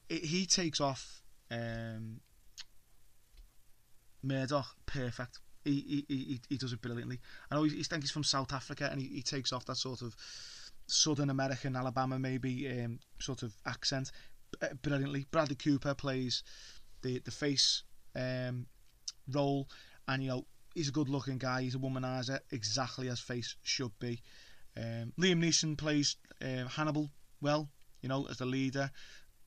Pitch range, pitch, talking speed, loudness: 125-140 Hz, 130 Hz, 150 wpm, -36 LUFS